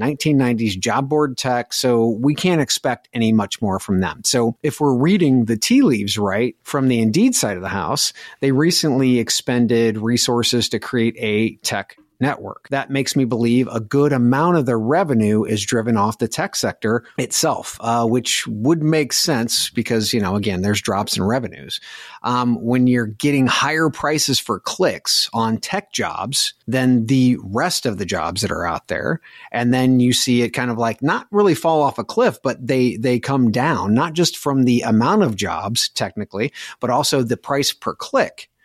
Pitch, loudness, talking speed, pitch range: 125 Hz, -18 LUFS, 190 wpm, 115-140 Hz